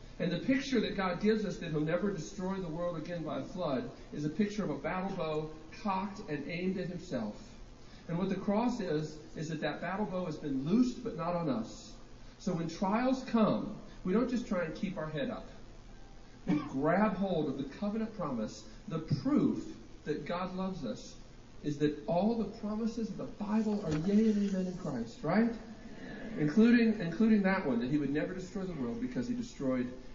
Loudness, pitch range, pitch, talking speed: -34 LUFS, 160-220 Hz, 190 Hz, 200 wpm